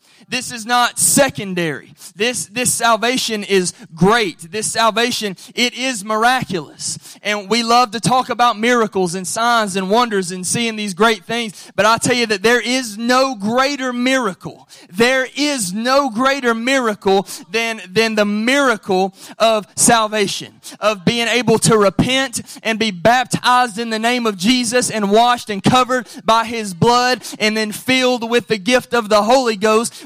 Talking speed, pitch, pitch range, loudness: 160 wpm, 230 Hz, 210-245 Hz, -16 LUFS